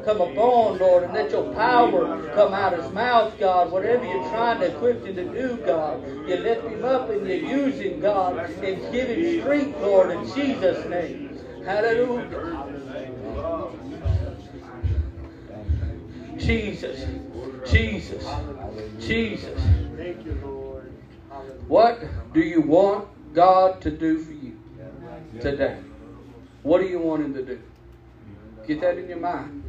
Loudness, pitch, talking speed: -23 LUFS, 180 Hz, 135 wpm